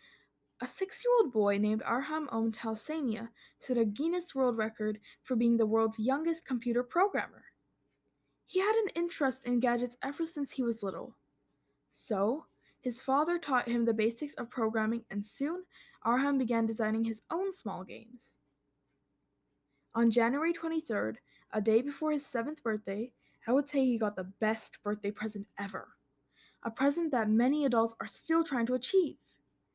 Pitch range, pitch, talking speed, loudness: 220-295 Hz, 245 Hz, 155 wpm, -32 LUFS